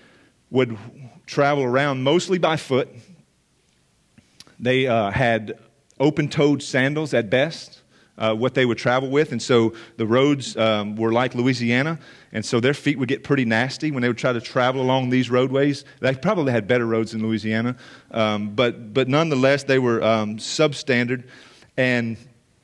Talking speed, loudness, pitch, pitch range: 160 wpm, -21 LUFS, 130 Hz, 115-140 Hz